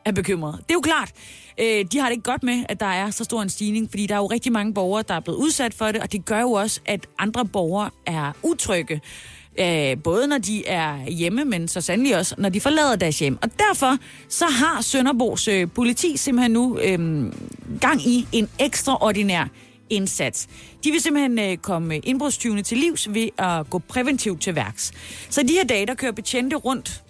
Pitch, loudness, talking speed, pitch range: 215 Hz, -22 LUFS, 200 wpm, 185-255 Hz